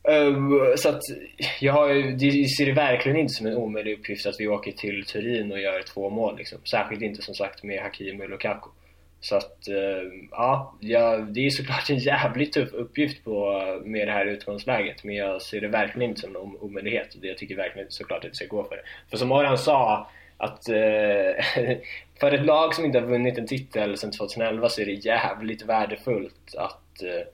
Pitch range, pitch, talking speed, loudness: 100-135 Hz, 110 Hz, 200 wpm, -25 LUFS